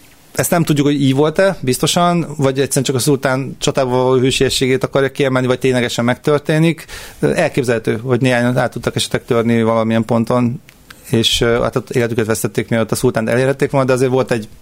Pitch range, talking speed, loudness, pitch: 120-140 Hz, 170 wpm, -15 LUFS, 130 Hz